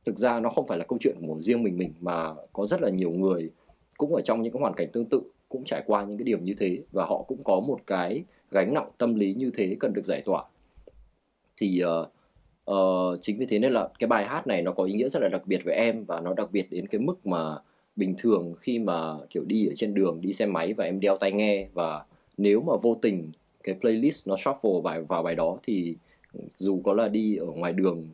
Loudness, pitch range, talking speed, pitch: -27 LUFS, 85-110 Hz, 255 wpm, 95 Hz